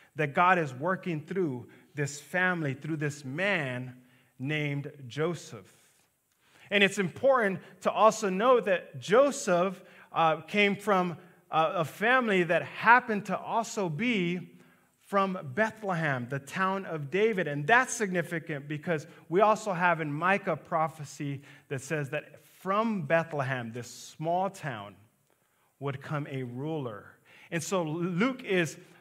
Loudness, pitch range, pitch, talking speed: -29 LUFS, 145-195 Hz, 165 Hz, 130 wpm